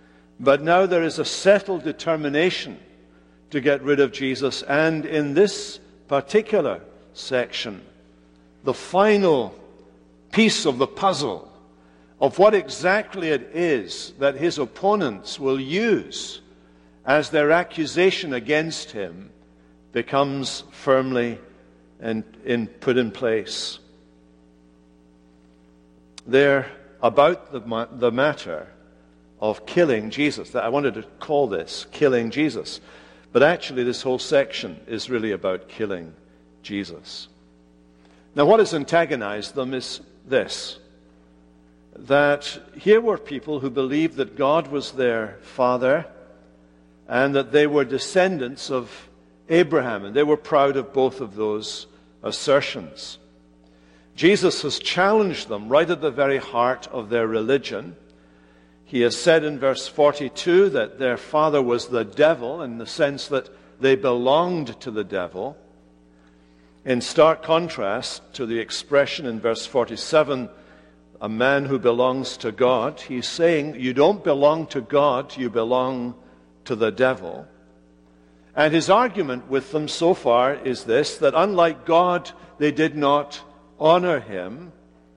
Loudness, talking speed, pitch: -21 LUFS, 130 wpm, 130 Hz